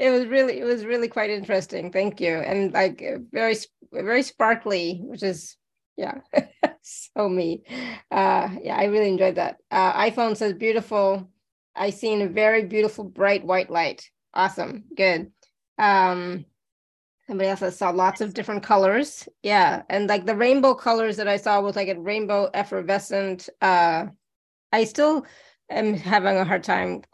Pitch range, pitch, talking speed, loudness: 190-225 Hz, 205 Hz, 155 wpm, -23 LUFS